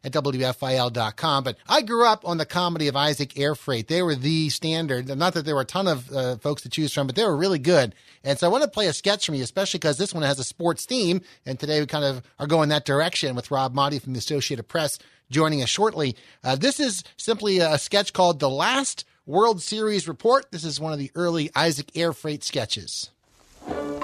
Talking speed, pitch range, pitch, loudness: 225 wpm, 140-175 Hz, 150 Hz, -23 LUFS